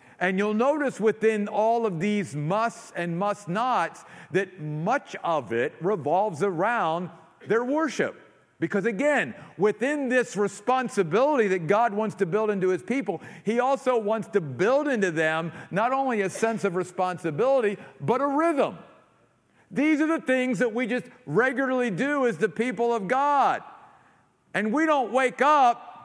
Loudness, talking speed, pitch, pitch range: -25 LUFS, 155 wpm, 220 Hz, 190-255 Hz